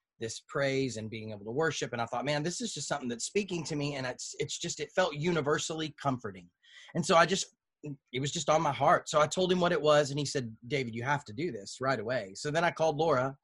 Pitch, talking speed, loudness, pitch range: 150 Hz, 270 wpm, -31 LUFS, 130-160 Hz